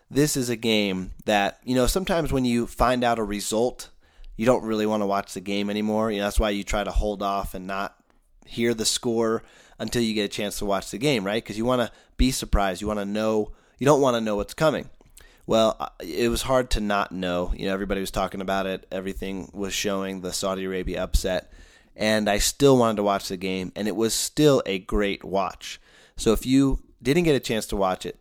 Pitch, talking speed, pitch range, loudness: 105 Hz, 235 wpm, 95-115 Hz, -24 LUFS